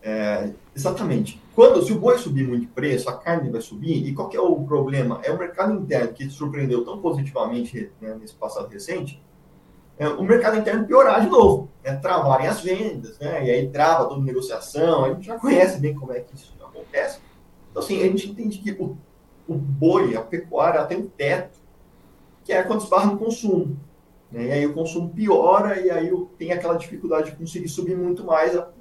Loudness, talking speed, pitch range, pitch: -21 LUFS, 205 wpm, 135-185 Hz, 165 Hz